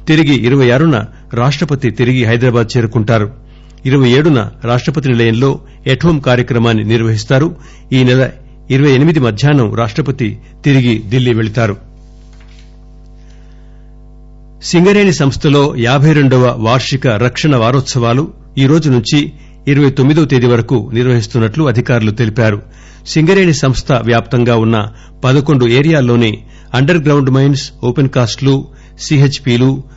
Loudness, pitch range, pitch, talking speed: -11 LUFS, 120-140 Hz, 130 Hz, 100 wpm